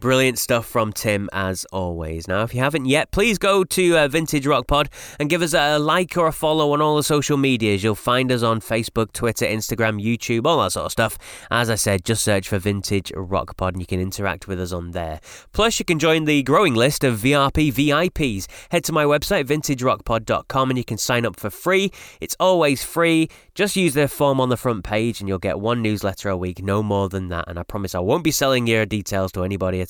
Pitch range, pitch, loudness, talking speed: 100-150 Hz, 120 Hz, -20 LUFS, 235 wpm